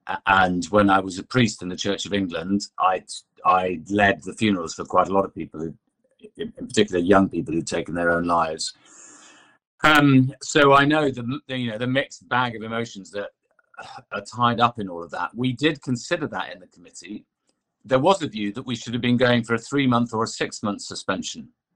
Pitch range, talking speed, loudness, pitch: 95-130 Hz, 215 wpm, -22 LUFS, 115 Hz